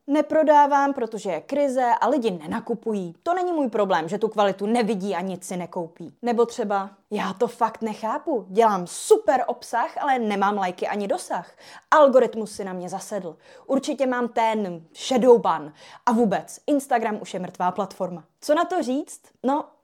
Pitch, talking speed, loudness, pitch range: 225 Hz, 165 wpm, -23 LUFS, 195-265 Hz